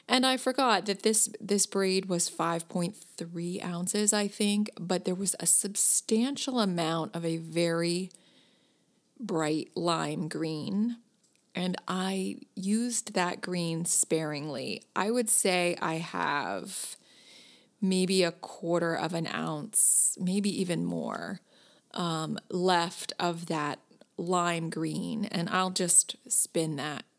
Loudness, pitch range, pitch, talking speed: -28 LUFS, 170-210 Hz, 180 Hz, 120 wpm